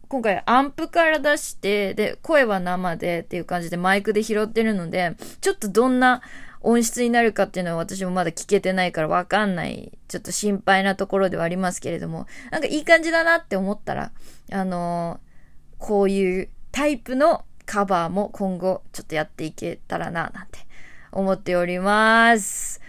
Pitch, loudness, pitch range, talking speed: 195 Hz, -22 LUFS, 180-230 Hz, 370 characters per minute